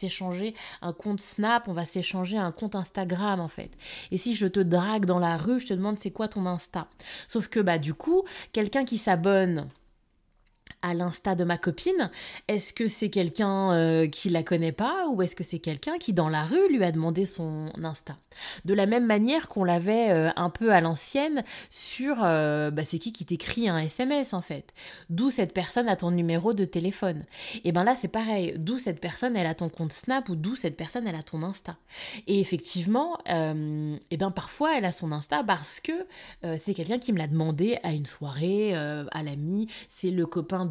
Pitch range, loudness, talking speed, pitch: 165-220 Hz, -28 LUFS, 210 wpm, 185 Hz